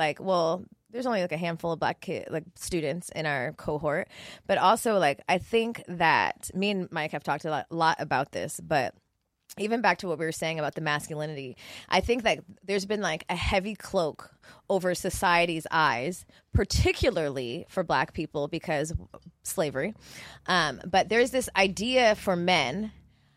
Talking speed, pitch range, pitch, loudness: 170 wpm, 160-205 Hz, 180 Hz, -28 LUFS